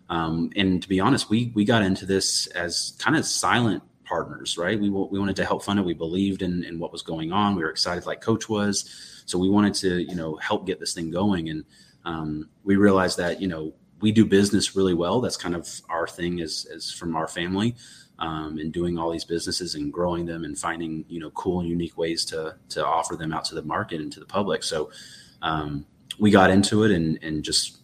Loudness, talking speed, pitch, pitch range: -24 LUFS, 235 wpm, 90 Hz, 80-100 Hz